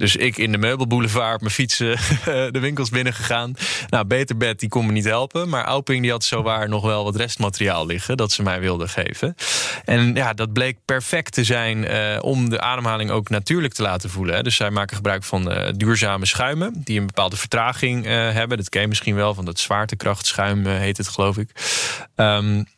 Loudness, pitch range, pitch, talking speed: -20 LUFS, 105-125 Hz, 110 Hz, 205 wpm